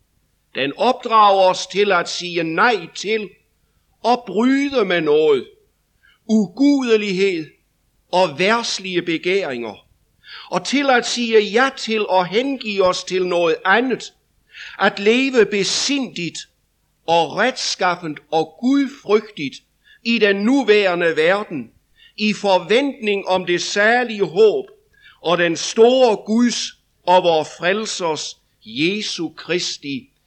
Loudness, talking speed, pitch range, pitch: -18 LUFS, 105 wpm, 180-240 Hz, 205 Hz